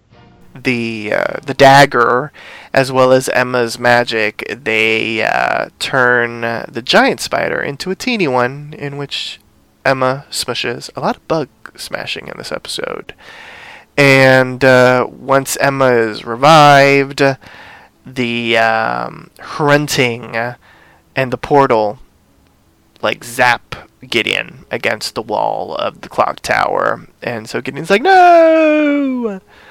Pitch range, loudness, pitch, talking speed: 120-145 Hz, -13 LUFS, 130 Hz, 120 wpm